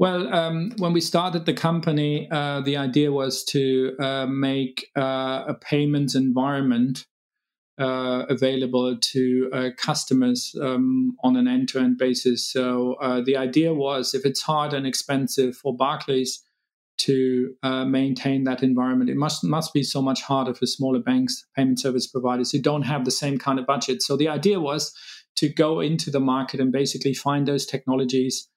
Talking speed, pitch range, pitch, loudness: 170 wpm, 130-150 Hz, 135 Hz, -23 LUFS